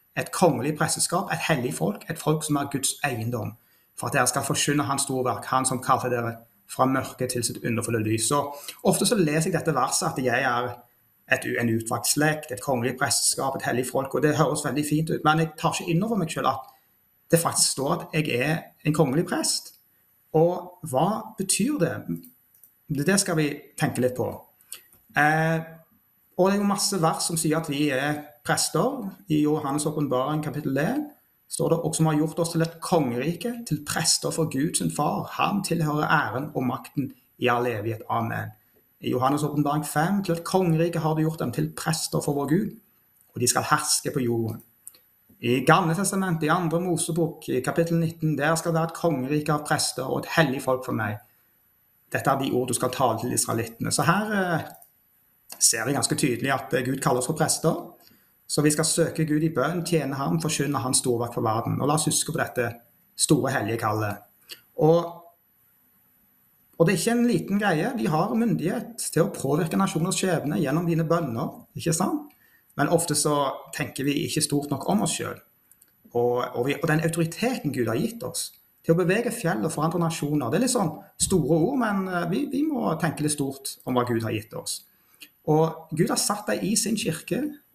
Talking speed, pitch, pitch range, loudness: 195 wpm, 155 Hz, 135-170 Hz, -25 LUFS